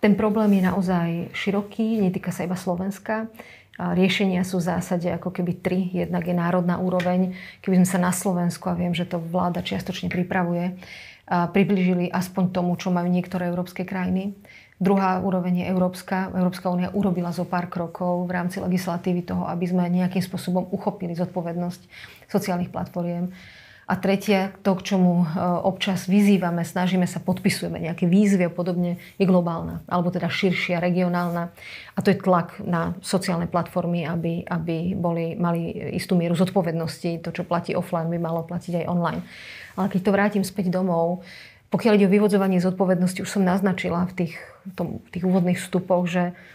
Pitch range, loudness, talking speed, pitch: 175-190 Hz, -24 LUFS, 165 wpm, 180 Hz